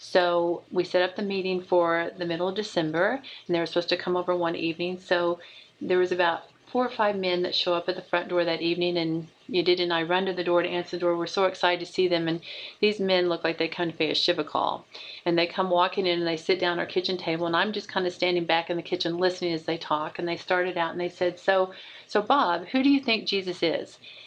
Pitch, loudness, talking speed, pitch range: 175 Hz, -26 LUFS, 275 wpm, 170-185 Hz